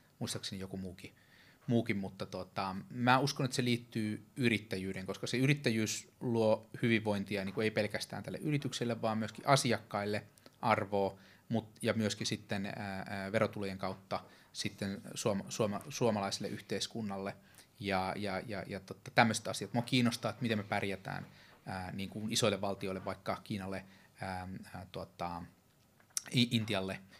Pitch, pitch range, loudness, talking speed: 105 Hz, 95-120 Hz, -36 LUFS, 130 wpm